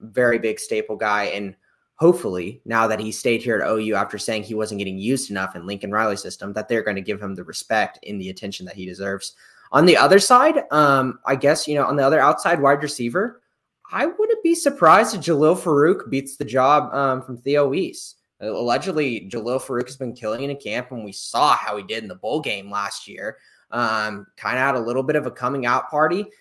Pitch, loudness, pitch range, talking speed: 120 Hz, -20 LUFS, 105-145 Hz, 225 wpm